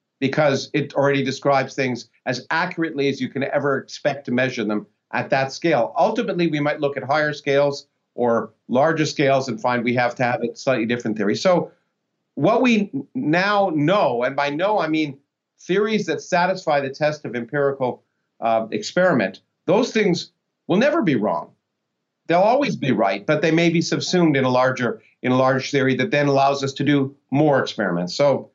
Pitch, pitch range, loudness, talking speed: 140 Hz, 130-160 Hz, -20 LUFS, 180 wpm